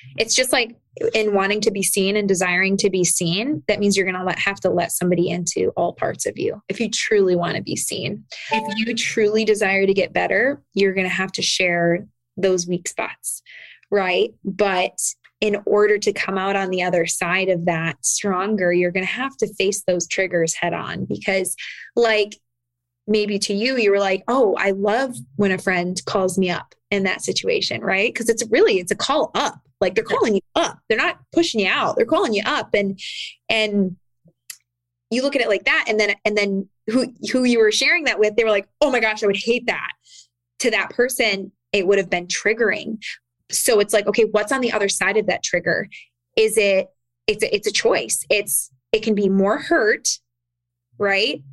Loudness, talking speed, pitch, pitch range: -20 LUFS, 210 wpm, 200 Hz, 180-220 Hz